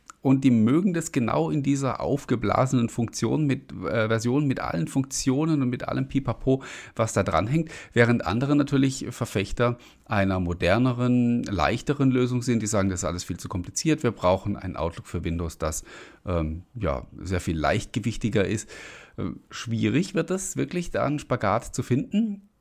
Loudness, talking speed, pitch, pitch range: -25 LUFS, 165 wpm, 120 Hz, 100-135 Hz